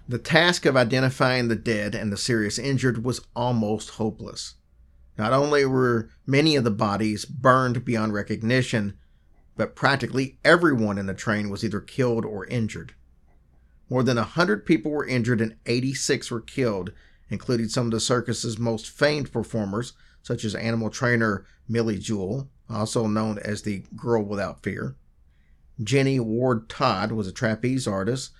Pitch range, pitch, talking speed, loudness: 105-125 Hz, 115 Hz, 155 wpm, -24 LUFS